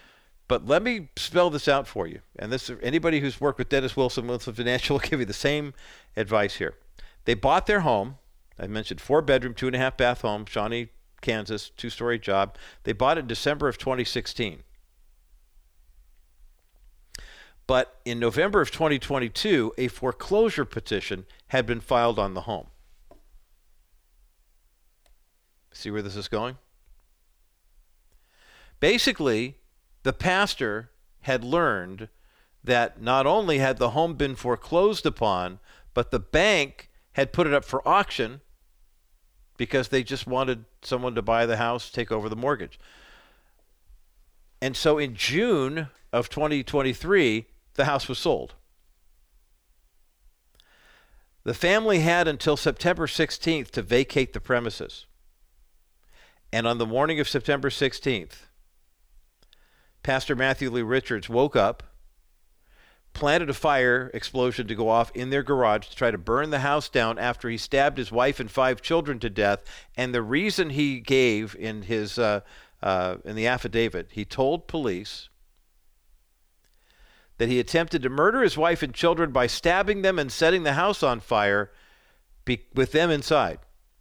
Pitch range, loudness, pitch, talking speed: 105-140 Hz, -25 LUFS, 125 Hz, 145 wpm